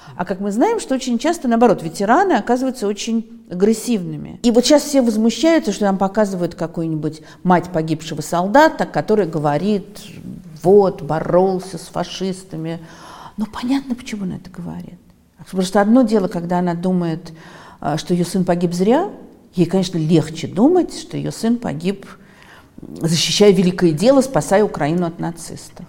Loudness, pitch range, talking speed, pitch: -17 LUFS, 170-225 Hz, 145 wpm, 190 Hz